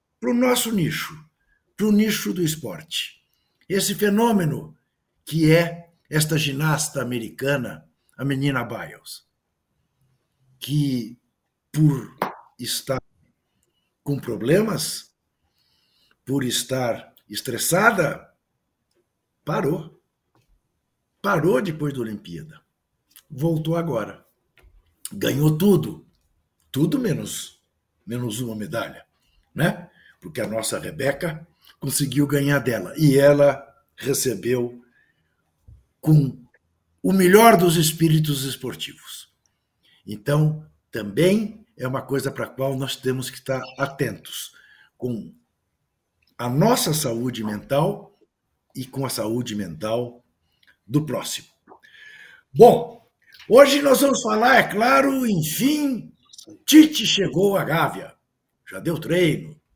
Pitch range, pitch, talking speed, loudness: 125-180 Hz, 145 Hz, 100 wpm, -21 LUFS